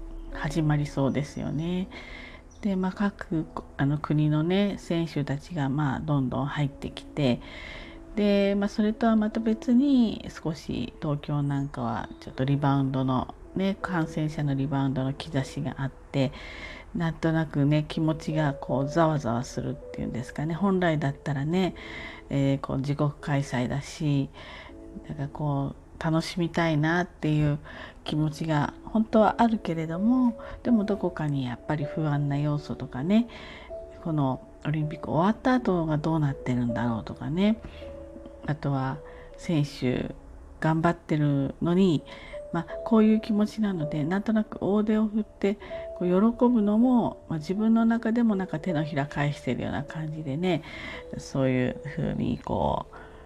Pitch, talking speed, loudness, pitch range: 155 Hz, 305 characters per minute, -27 LUFS, 140-195 Hz